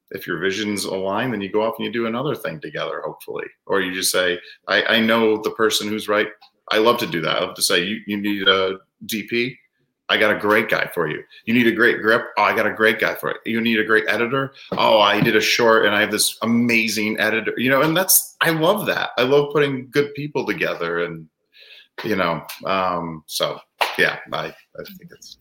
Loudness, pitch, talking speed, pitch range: -19 LUFS, 115 Hz, 235 wpm, 105-135 Hz